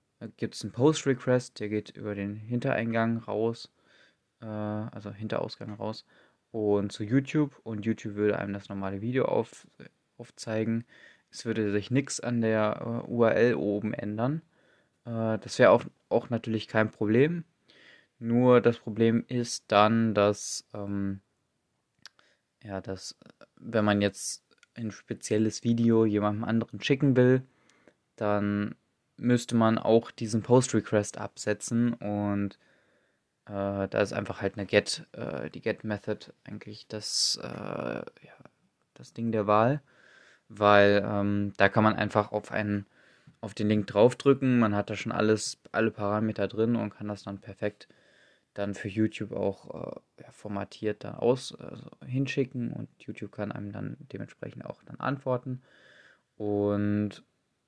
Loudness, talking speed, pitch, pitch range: -28 LUFS, 140 wpm, 110 Hz, 105-120 Hz